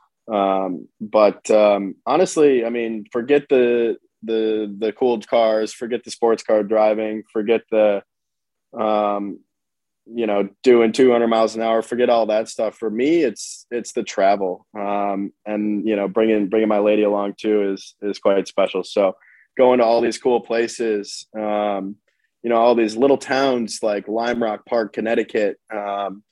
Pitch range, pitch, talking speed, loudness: 105-115 Hz, 110 Hz, 160 wpm, -19 LUFS